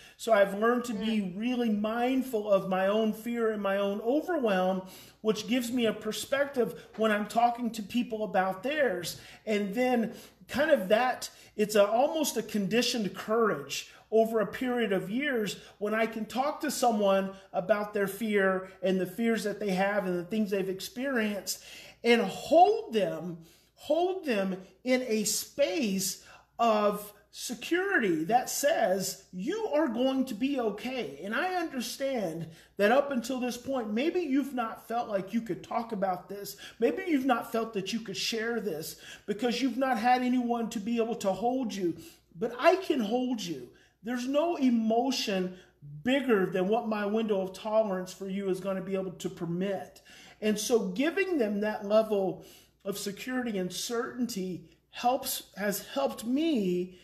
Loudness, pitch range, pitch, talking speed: -30 LUFS, 195-250 Hz, 220 Hz, 165 wpm